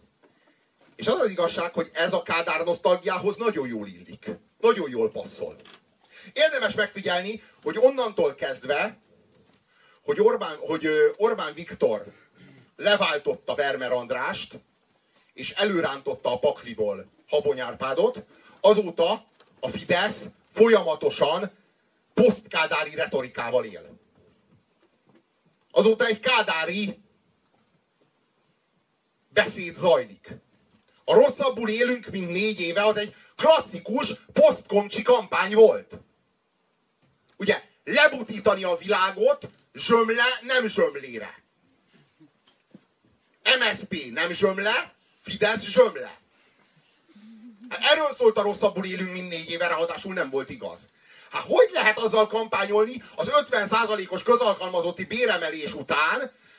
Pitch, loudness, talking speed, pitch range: 220 Hz, -23 LUFS, 100 wpm, 195-305 Hz